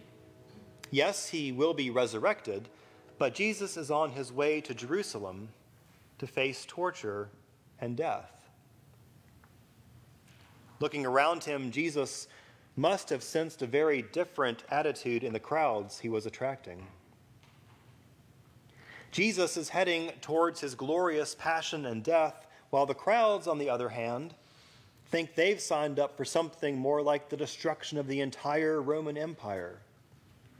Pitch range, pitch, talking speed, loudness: 120-155 Hz, 135 Hz, 130 wpm, -32 LUFS